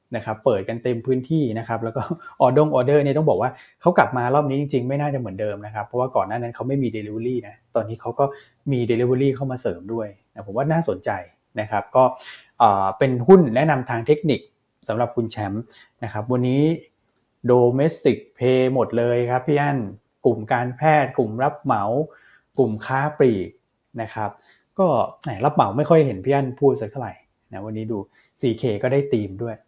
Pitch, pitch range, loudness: 125 Hz, 115-140 Hz, -21 LUFS